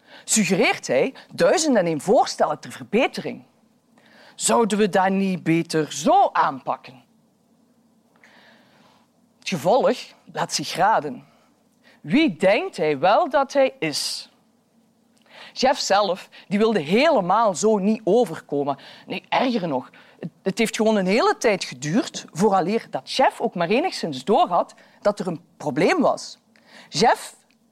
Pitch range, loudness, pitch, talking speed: 190-240 Hz, -21 LUFS, 220 Hz, 125 wpm